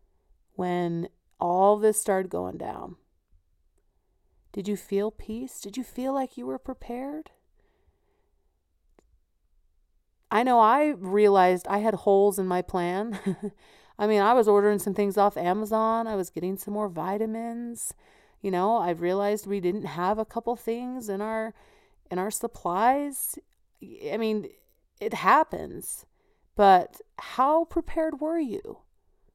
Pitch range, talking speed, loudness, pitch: 190-240 Hz, 135 wpm, -26 LUFS, 210 Hz